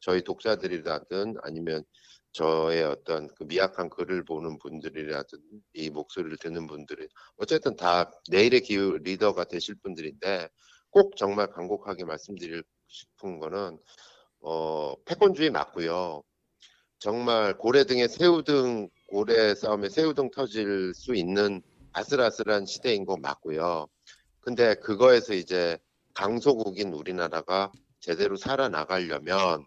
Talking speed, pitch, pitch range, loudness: 285 characters per minute, 95 Hz, 85-115 Hz, -27 LUFS